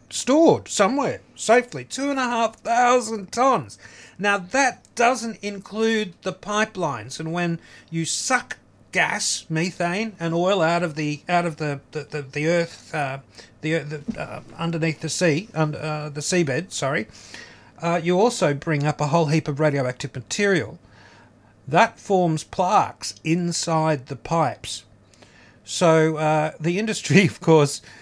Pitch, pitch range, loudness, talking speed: 160 Hz, 145-190 Hz, -22 LUFS, 145 wpm